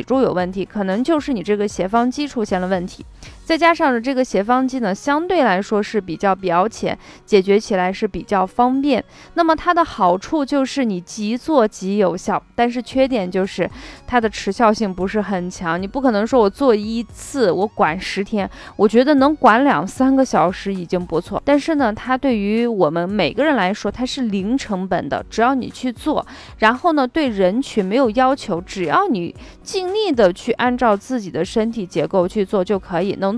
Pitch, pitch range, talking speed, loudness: 220 Hz, 190-260 Hz, 285 characters per minute, -18 LUFS